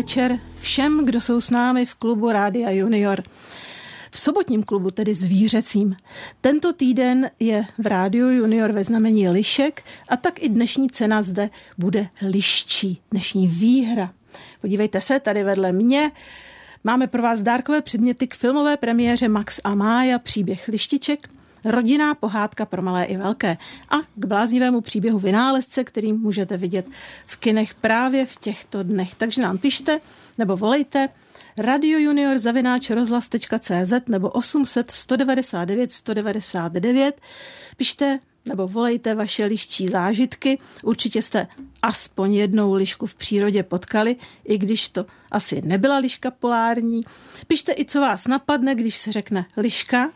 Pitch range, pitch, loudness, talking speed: 205-255 Hz, 225 Hz, -20 LUFS, 135 wpm